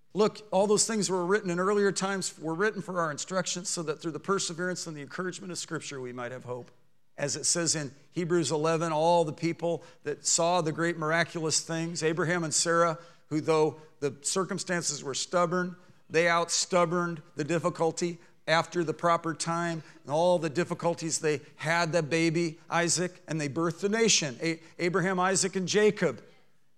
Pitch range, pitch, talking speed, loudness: 155-180 Hz, 170 Hz, 170 wpm, -28 LUFS